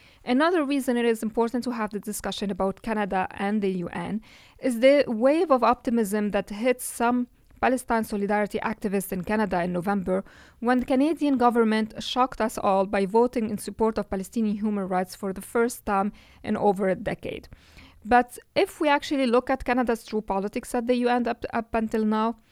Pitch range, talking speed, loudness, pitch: 205-245 Hz, 180 wpm, -25 LUFS, 225 Hz